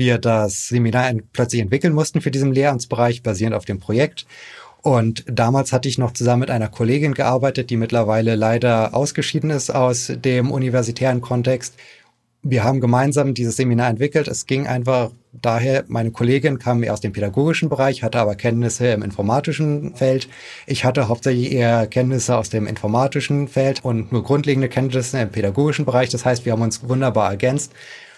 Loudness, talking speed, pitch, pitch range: -19 LUFS, 170 wpm, 125 Hz, 115-135 Hz